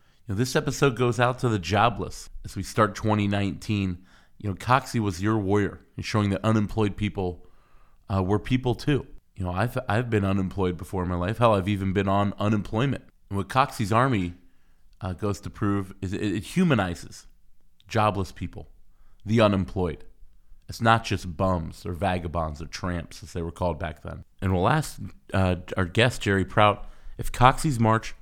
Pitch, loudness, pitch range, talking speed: 100 Hz, -26 LUFS, 90-110 Hz, 180 wpm